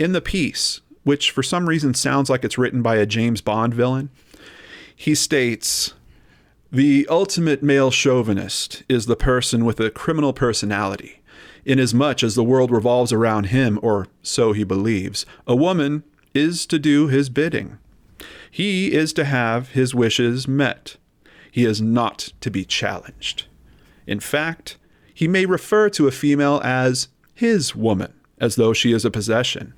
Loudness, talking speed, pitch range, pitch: -19 LUFS, 155 wpm, 115-145 Hz, 130 Hz